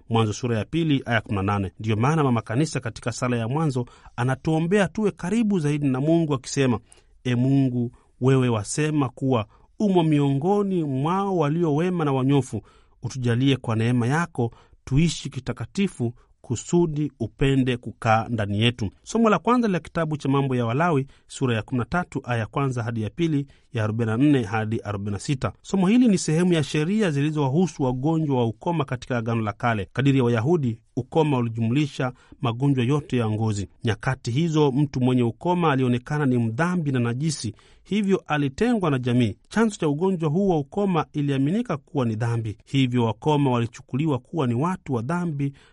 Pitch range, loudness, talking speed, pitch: 120-160 Hz, -24 LUFS, 150 wpm, 135 Hz